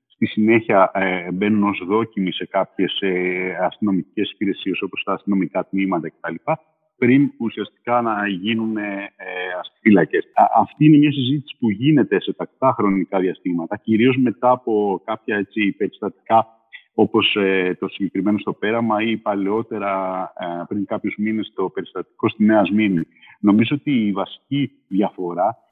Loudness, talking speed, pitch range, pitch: -20 LUFS, 130 wpm, 95-115 Hz, 105 Hz